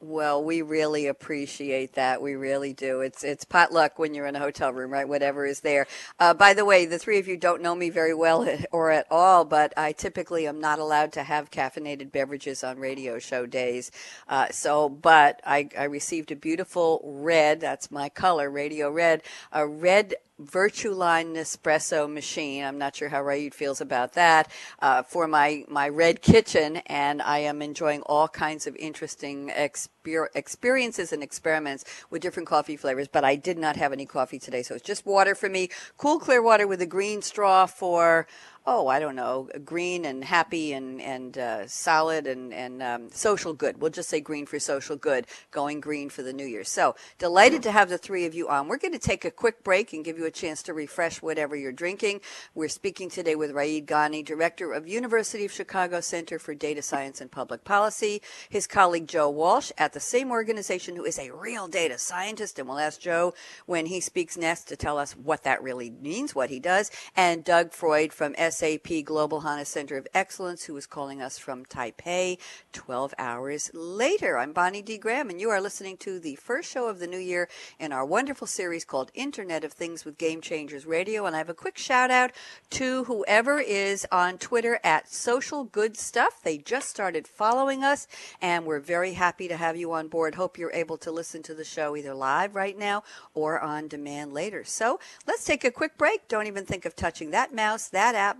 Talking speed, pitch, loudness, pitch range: 205 wpm, 160 Hz, -26 LUFS, 145-185 Hz